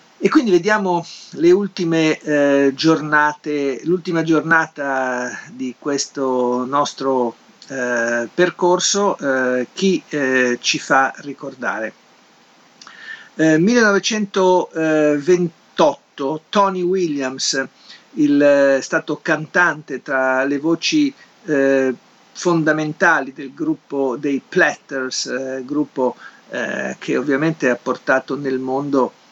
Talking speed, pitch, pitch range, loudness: 90 wpm, 150 Hz, 130-175 Hz, -18 LUFS